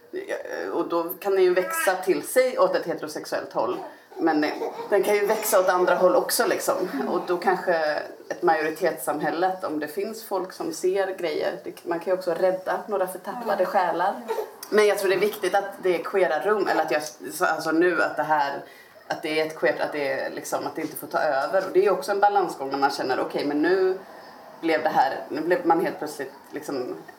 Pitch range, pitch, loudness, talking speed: 170-210 Hz, 185 Hz, -24 LUFS, 215 wpm